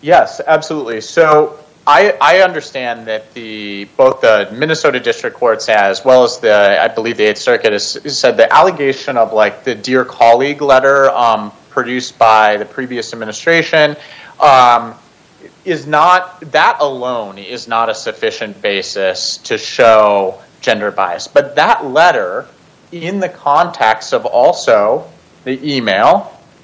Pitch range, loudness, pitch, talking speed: 110-155 Hz, -12 LUFS, 130 Hz, 140 wpm